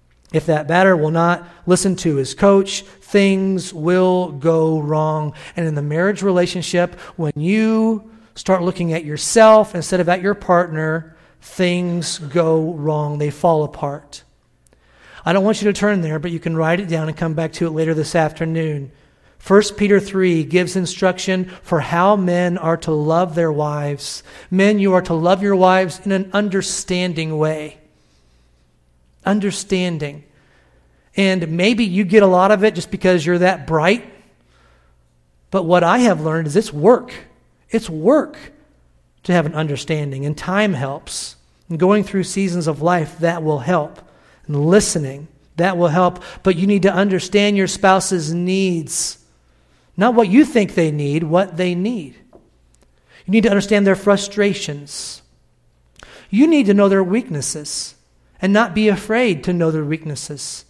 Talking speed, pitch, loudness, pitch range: 160 wpm, 175 Hz, -17 LUFS, 155-195 Hz